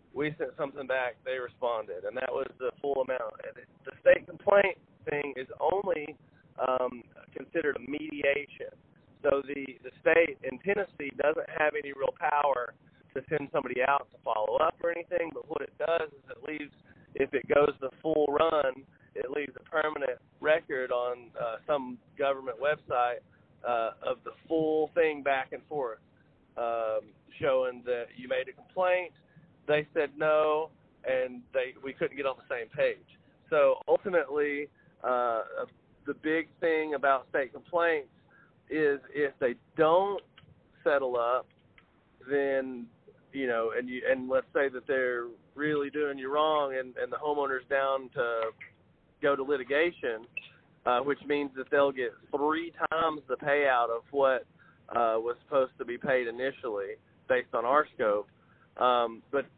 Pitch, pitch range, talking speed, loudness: 145 Hz, 130-170 Hz, 155 wpm, -30 LUFS